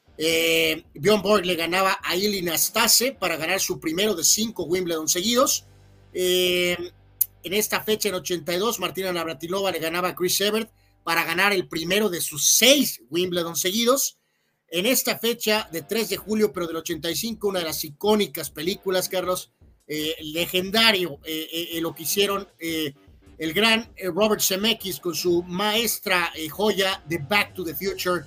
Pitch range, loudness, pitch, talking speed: 165-205 Hz, -22 LUFS, 180 Hz, 160 wpm